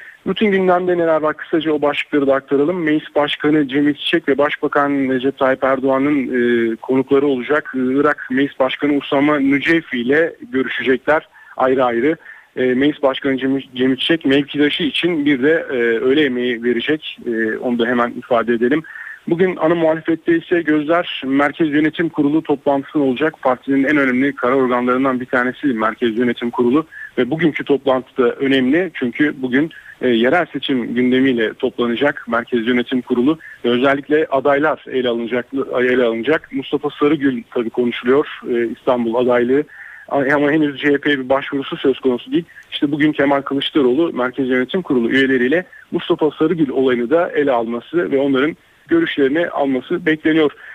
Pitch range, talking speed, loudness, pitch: 125-155 Hz, 145 wpm, -17 LUFS, 140 Hz